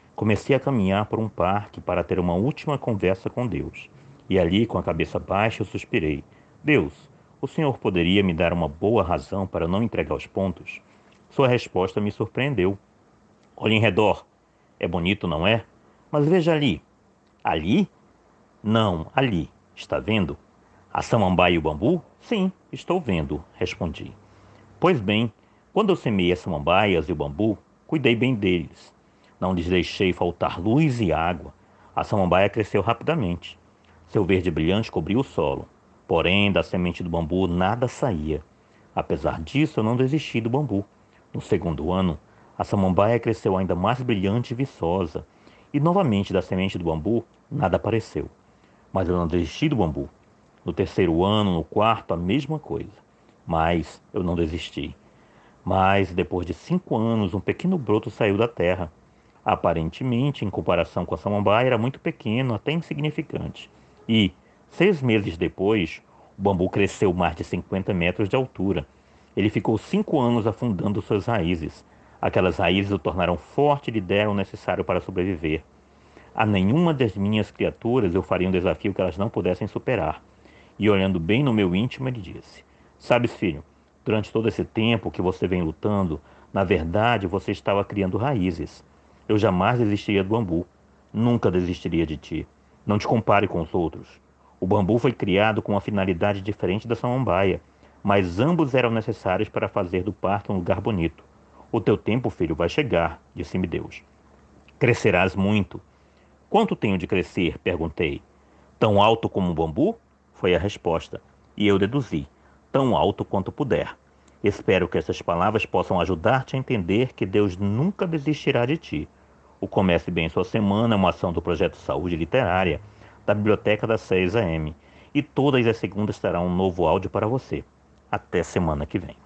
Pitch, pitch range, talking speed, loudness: 100 Hz, 90-115 Hz, 160 wpm, -23 LUFS